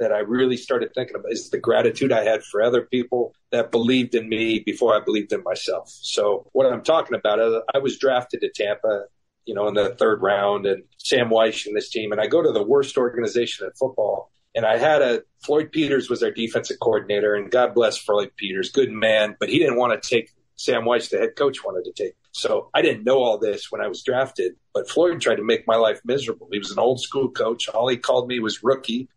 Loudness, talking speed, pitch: -22 LUFS, 240 wpm, 135 Hz